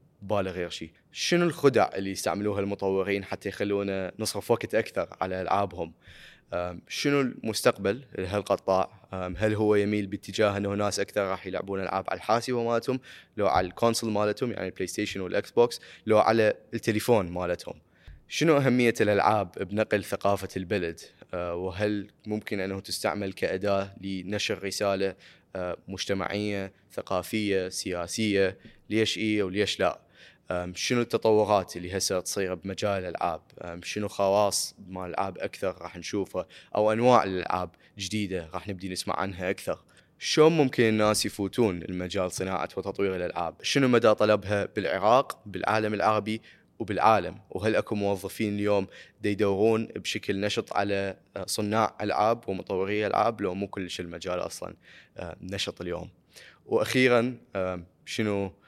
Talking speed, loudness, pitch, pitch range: 125 wpm, -28 LUFS, 100 Hz, 95-110 Hz